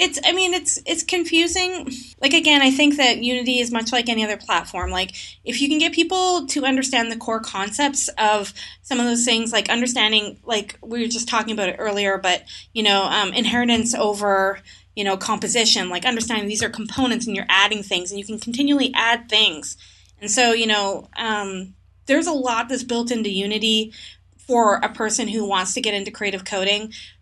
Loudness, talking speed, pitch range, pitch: -19 LUFS, 200 wpm, 205-255 Hz, 230 Hz